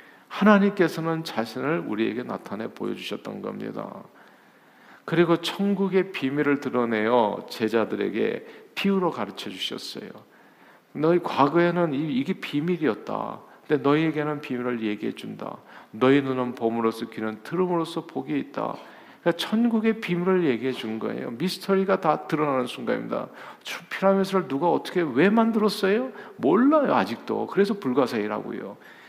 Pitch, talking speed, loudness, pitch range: 170 Hz, 335 characters per minute, -25 LUFS, 130-195 Hz